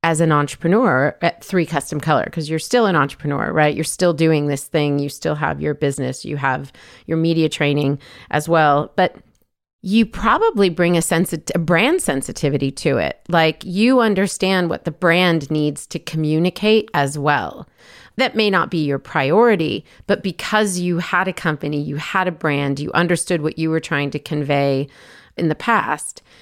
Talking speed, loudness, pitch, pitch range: 180 wpm, -18 LUFS, 160 Hz, 145-180 Hz